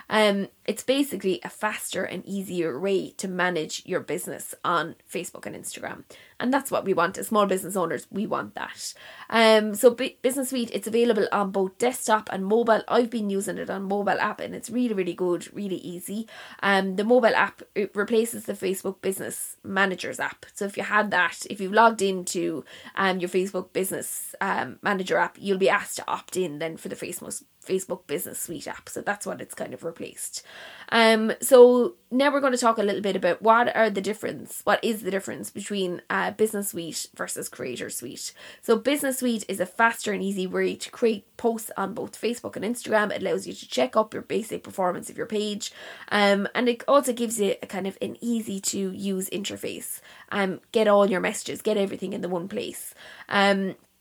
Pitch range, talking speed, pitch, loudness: 190-230 Hz, 210 wpm, 200 Hz, -25 LUFS